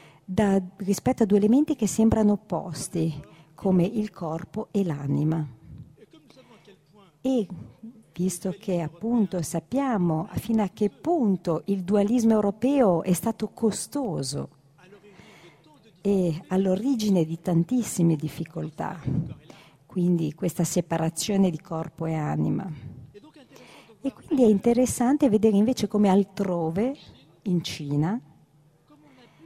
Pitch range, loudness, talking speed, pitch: 160-215 Hz, -25 LUFS, 100 wpm, 190 Hz